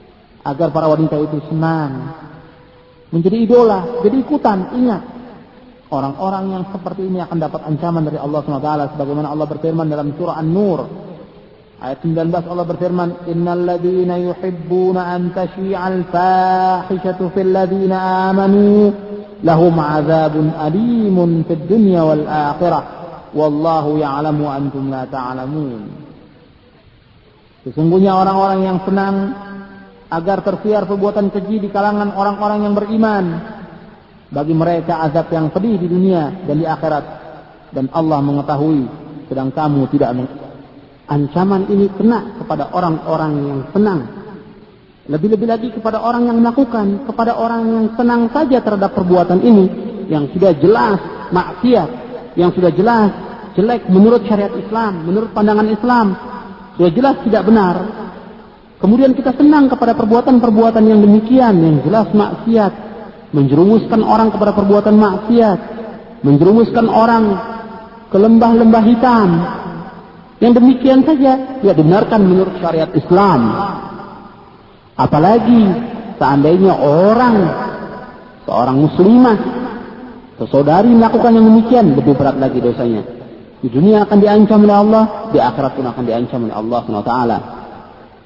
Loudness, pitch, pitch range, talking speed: -13 LUFS, 190 Hz, 160-215 Hz, 120 wpm